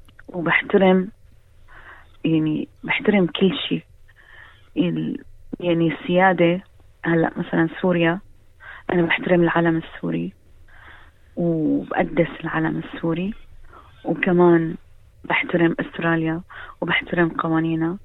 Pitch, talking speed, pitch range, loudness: 170 Hz, 75 wpm, 160-180 Hz, -21 LUFS